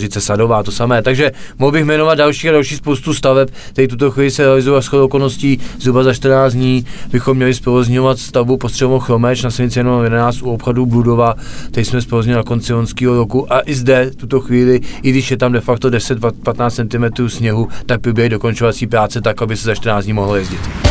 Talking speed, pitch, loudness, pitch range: 205 wpm, 125 Hz, -13 LUFS, 115-130 Hz